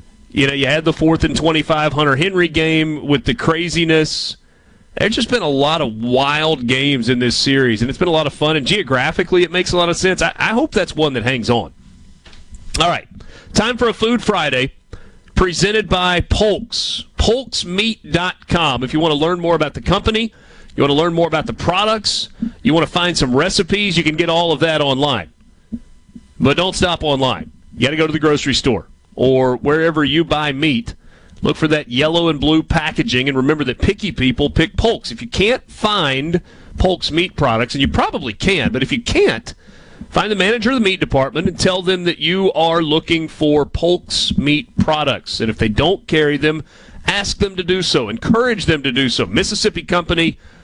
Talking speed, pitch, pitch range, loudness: 205 wpm, 160 Hz, 140-180 Hz, -16 LUFS